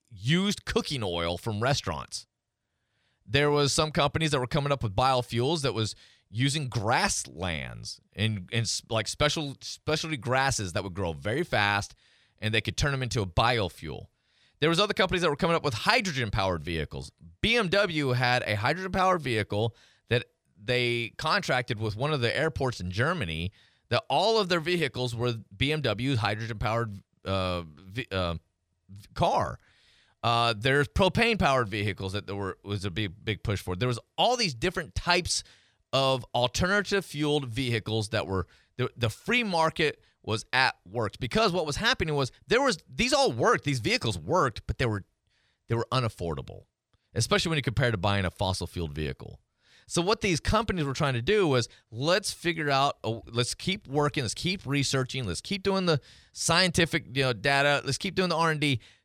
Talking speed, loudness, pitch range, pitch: 175 wpm, -28 LUFS, 105-150 Hz, 125 Hz